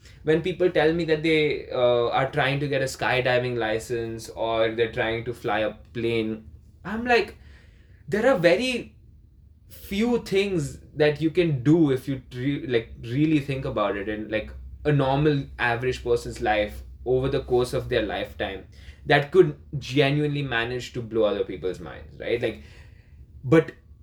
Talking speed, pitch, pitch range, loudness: 160 wpm, 125 Hz, 110-150 Hz, -24 LUFS